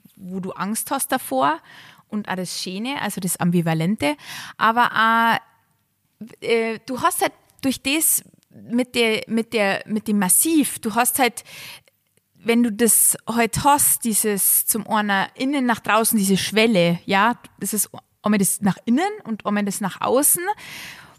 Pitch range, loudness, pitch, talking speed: 200-250 Hz, -20 LUFS, 220 Hz, 160 wpm